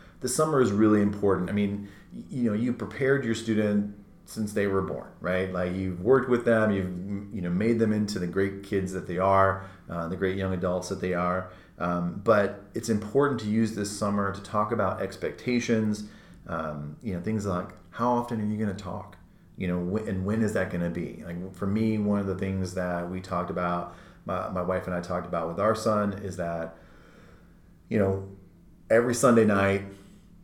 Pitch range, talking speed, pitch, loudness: 90-110 Hz, 205 wpm, 100 Hz, -27 LUFS